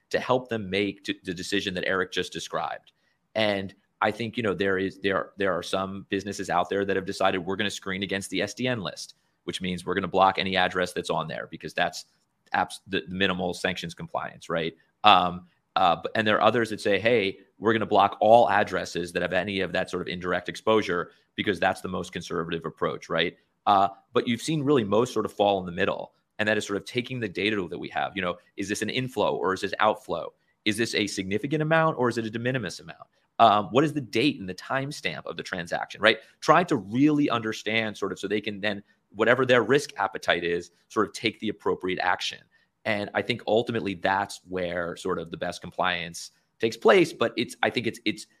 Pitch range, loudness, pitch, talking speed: 95-115 Hz, -26 LUFS, 100 Hz, 230 wpm